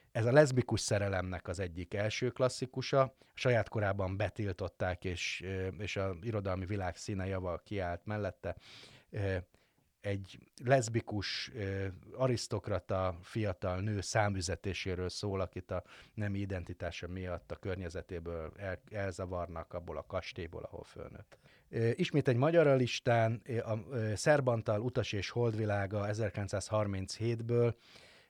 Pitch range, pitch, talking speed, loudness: 95-115 Hz, 105 Hz, 110 wpm, -35 LUFS